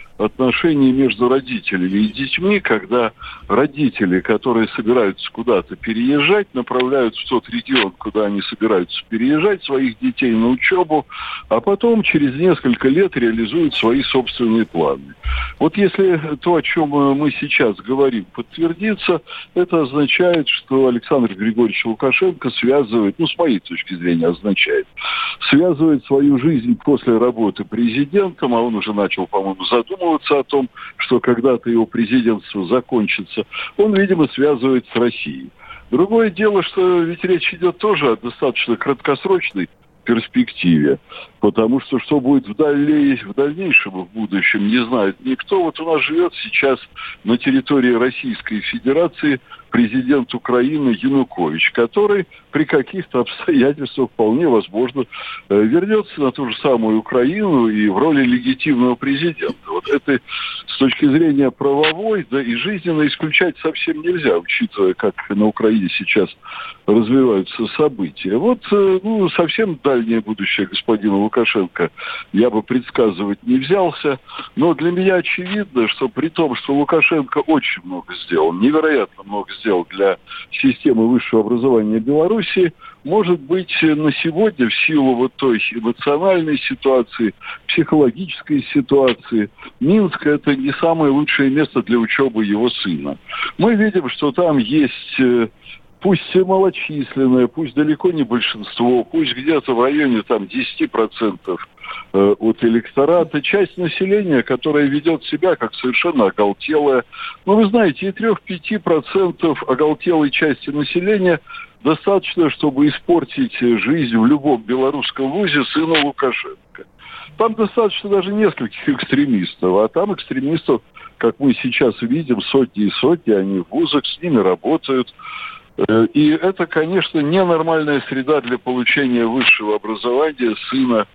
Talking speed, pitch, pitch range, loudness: 130 wpm, 150 Hz, 120-195 Hz, -16 LUFS